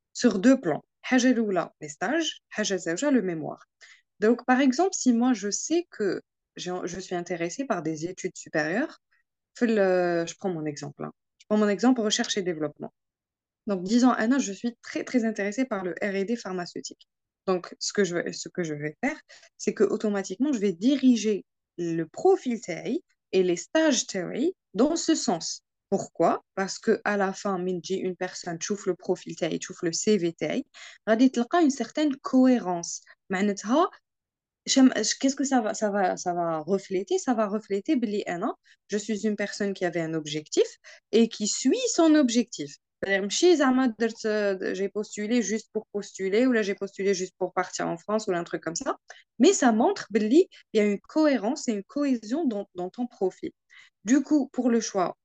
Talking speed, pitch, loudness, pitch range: 175 wpm, 210 Hz, -26 LUFS, 185-255 Hz